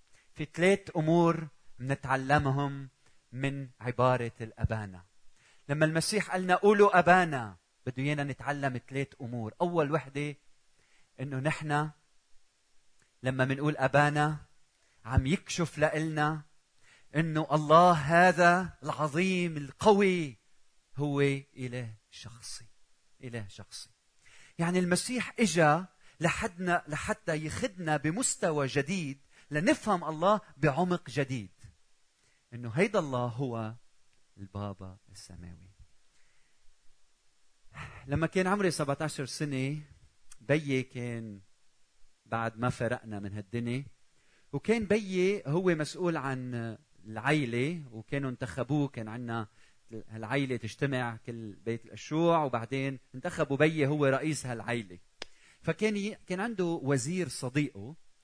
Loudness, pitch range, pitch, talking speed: -30 LUFS, 120-165 Hz, 140 Hz, 95 wpm